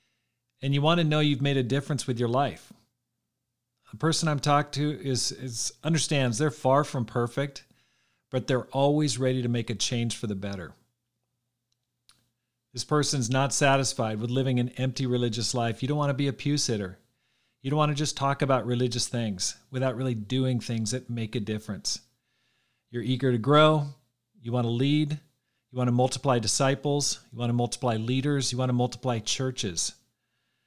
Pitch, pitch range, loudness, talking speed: 125 Hz, 120-140 Hz, -27 LUFS, 180 wpm